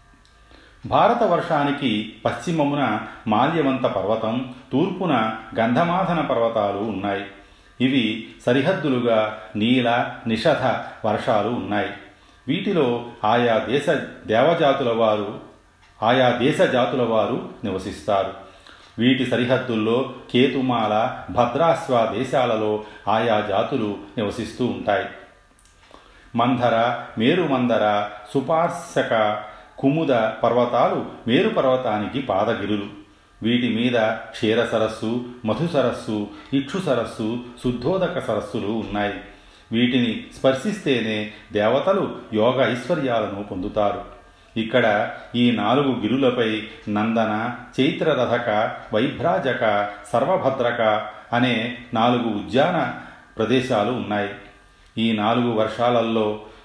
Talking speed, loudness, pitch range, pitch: 80 wpm, -21 LUFS, 105-125 Hz, 115 Hz